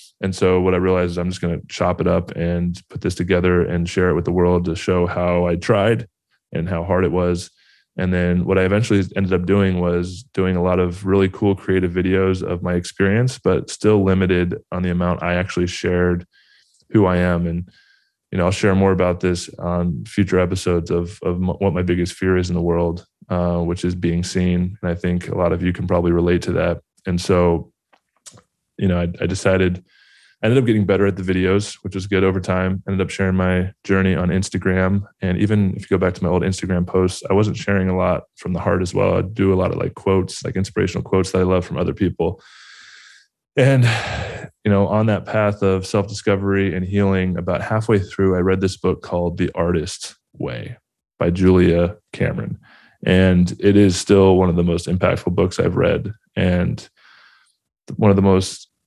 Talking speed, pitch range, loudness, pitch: 210 wpm, 90-95 Hz, -19 LUFS, 95 Hz